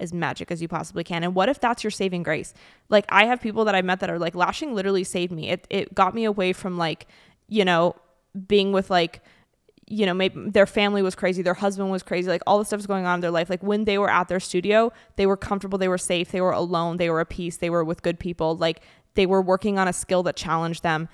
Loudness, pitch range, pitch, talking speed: -23 LUFS, 175-200 Hz, 185 Hz, 265 wpm